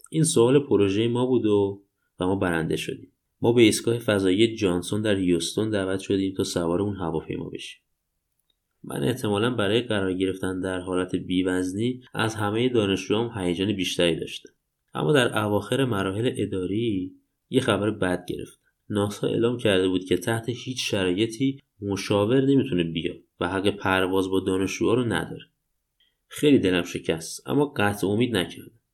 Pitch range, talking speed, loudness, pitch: 95-115 Hz, 150 wpm, -24 LUFS, 100 Hz